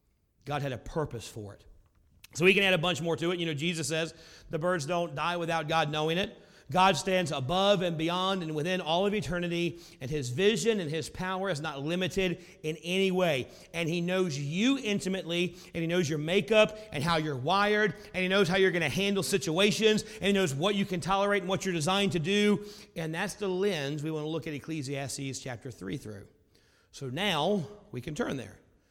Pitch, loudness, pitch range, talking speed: 170 Hz, -29 LUFS, 150-190 Hz, 215 wpm